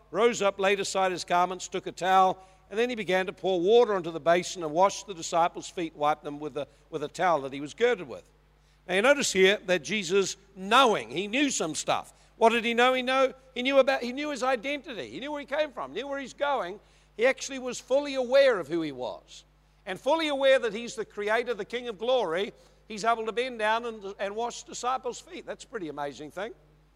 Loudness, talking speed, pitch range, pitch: -27 LUFS, 235 wpm, 185-260 Hz, 215 Hz